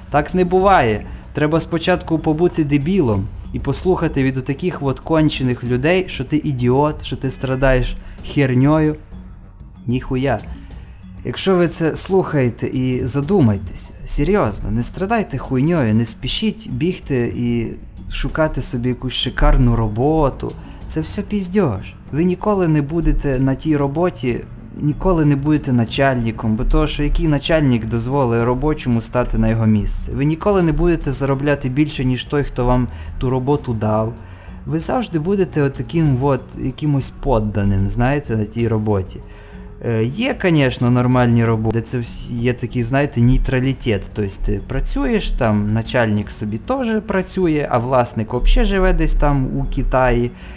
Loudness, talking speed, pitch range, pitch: -18 LUFS, 140 wpm, 115-155 Hz, 130 Hz